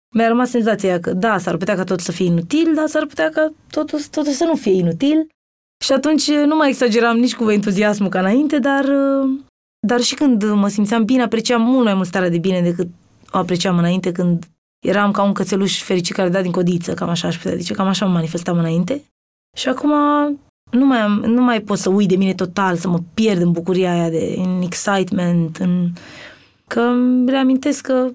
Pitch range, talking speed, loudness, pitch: 180-260 Hz, 210 wpm, -17 LUFS, 210 Hz